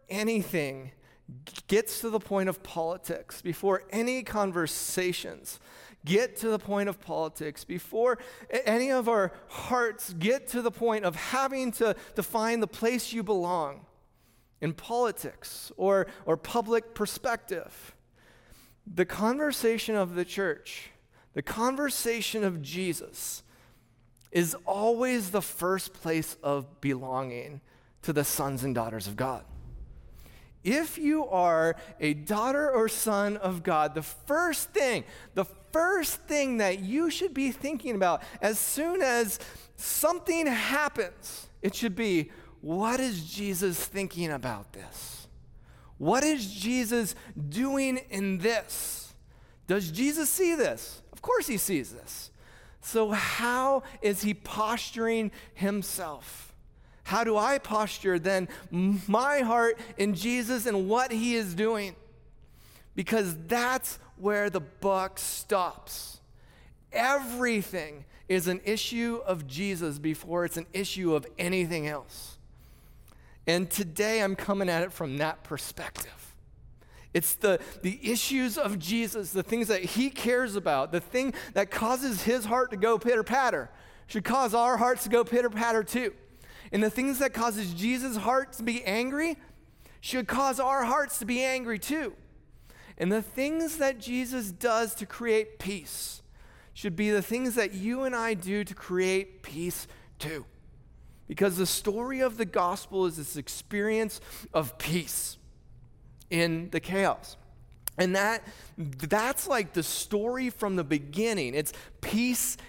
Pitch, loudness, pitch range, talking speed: 205 Hz, -29 LUFS, 175-240 Hz, 135 wpm